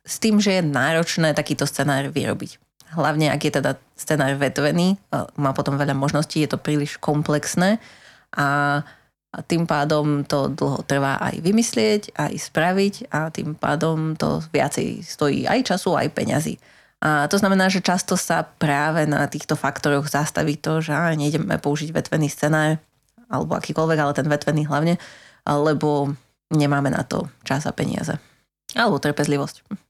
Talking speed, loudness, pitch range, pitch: 150 wpm, -21 LUFS, 145-165 Hz, 150 Hz